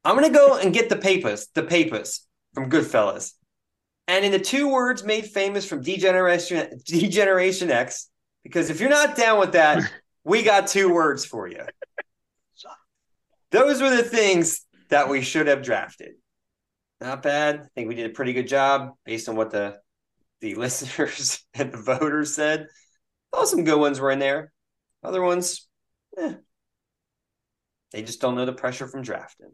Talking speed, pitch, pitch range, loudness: 165 wpm, 155 Hz, 130-195 Hz, -22 LUFS